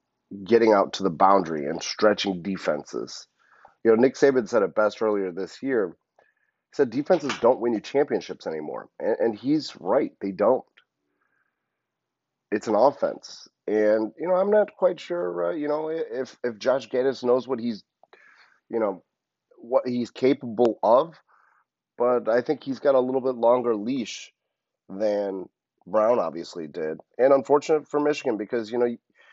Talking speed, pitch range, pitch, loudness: 160 wpm, 105-140 Hz, 120 Hz, -24 LUFS